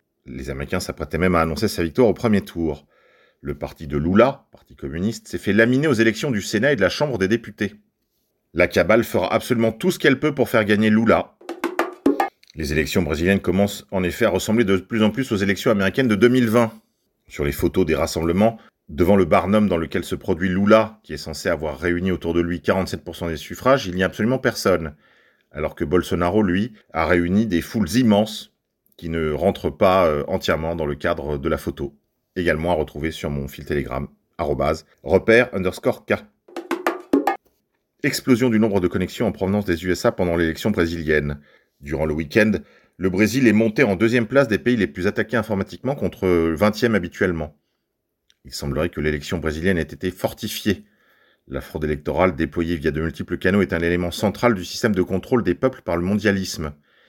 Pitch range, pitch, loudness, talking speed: 80-110 Hz, 90 Hz, -21 LUFS, 190 wpm